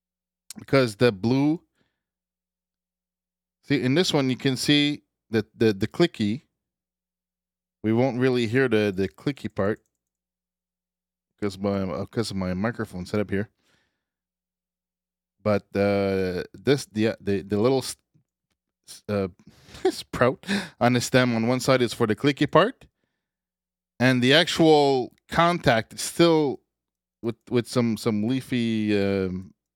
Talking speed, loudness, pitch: 130 wpm, -24 LUFS, 105 Hz